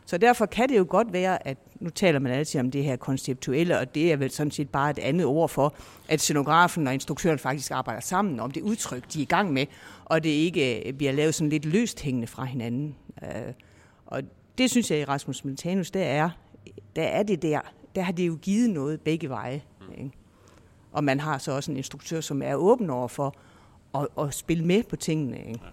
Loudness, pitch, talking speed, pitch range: -26 LUFS, 150 Hz, 220 wpm, 135-170 Hz